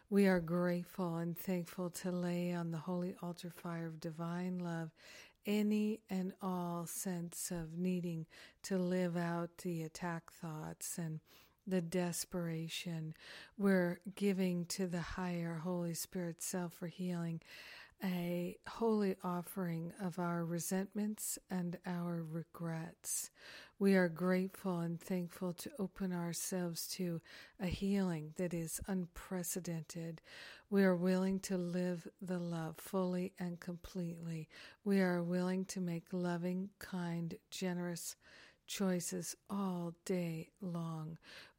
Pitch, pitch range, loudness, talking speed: 180 Hz, 170-185 Hz, -40 LUFS, 125 wpm